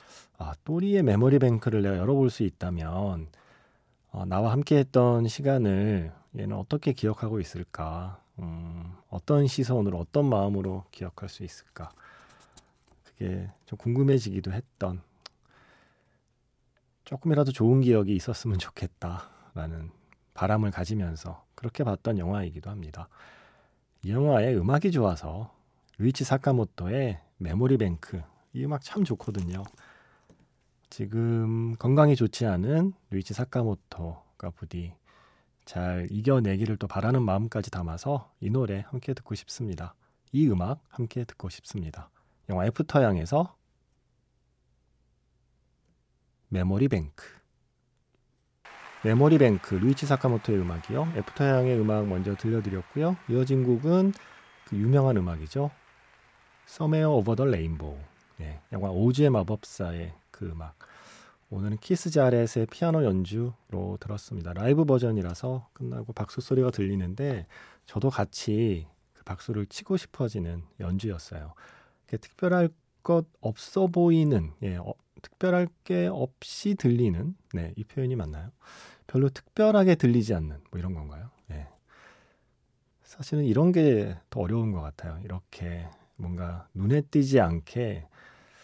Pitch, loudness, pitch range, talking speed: 110 Hz, -27 LUFS, 90-135 Hz, 275 characters per minute